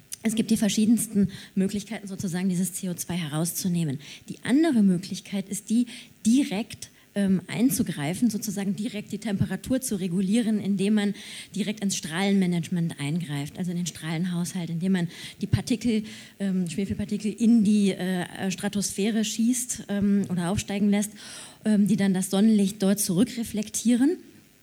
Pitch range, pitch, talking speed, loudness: 185-215 Hz, 200 Hz, 135 wpm, -26 LUFS